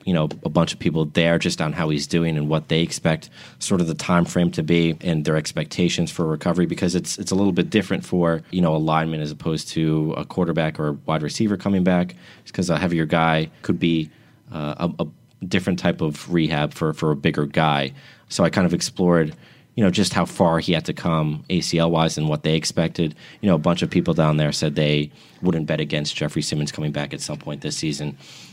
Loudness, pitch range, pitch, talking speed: -22 LUFS, 75-85 Hz, 80 Hz, 230 wpm